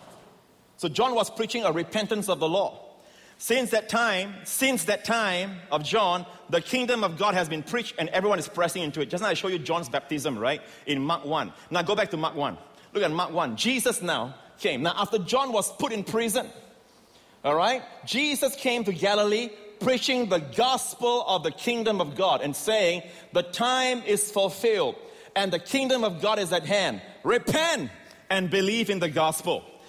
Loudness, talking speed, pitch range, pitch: -26 LUFS, 190 wpm, 175-240 Hz, 205 Hz